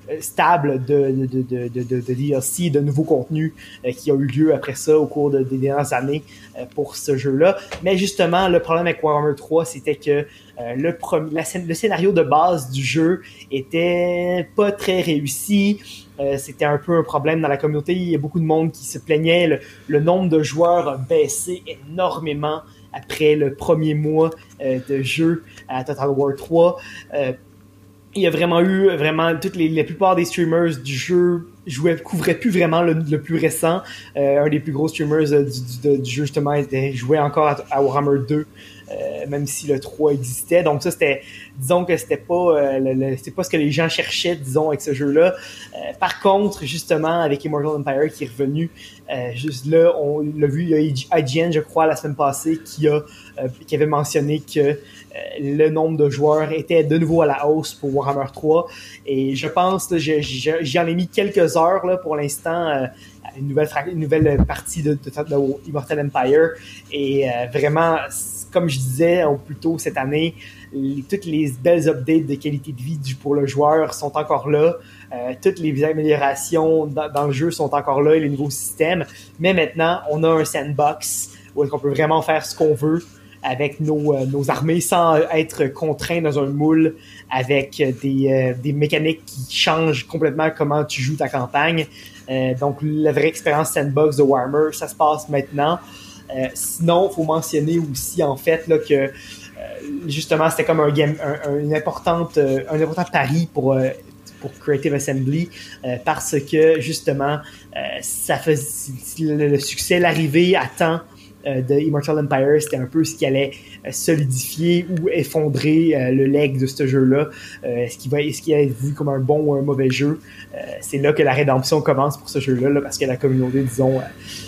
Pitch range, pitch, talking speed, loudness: 140-160 Hz, 150 Hz, 200 wpm, -19 LUFS